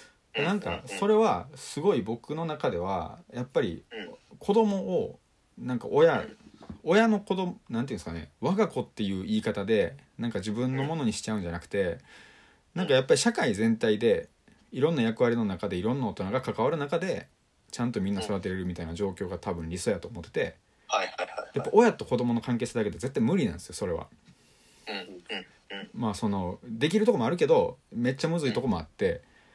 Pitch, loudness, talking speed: 130 Hz, -29 LUFS, 370 characters per minute